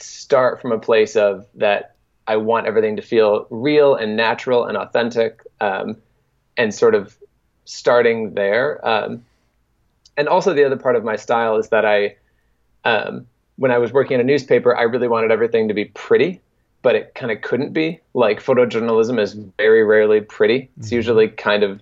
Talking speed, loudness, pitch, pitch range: 180 wpm, -17 LUFS, 115 Hz, 110-145 Hz